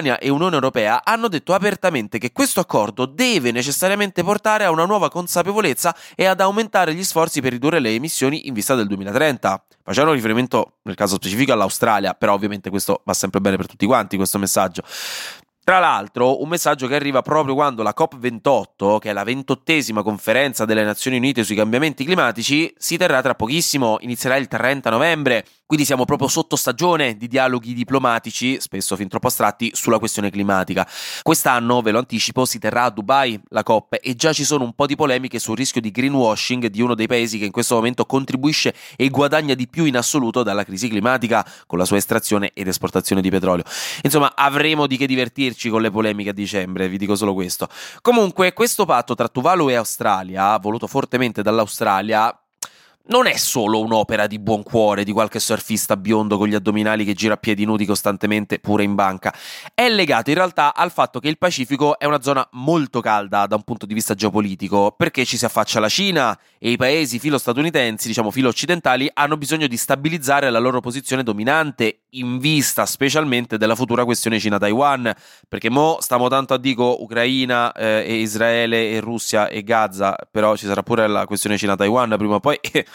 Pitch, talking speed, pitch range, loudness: 120 Hz, 185 wpm, 105-140 Hz, -18 LUFS